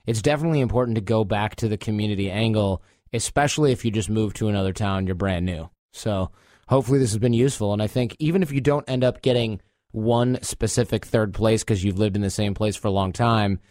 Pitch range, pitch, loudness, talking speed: 100-125 Hz, 110 Hz, -23 LUFS, 230 wpm